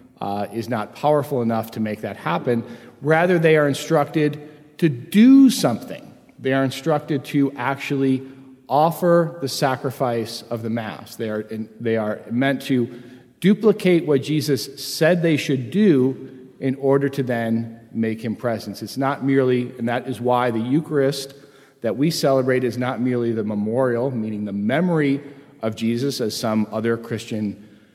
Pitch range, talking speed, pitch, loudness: 115-145 Hz, 160 wpm, 130 Hz, -21 LUFS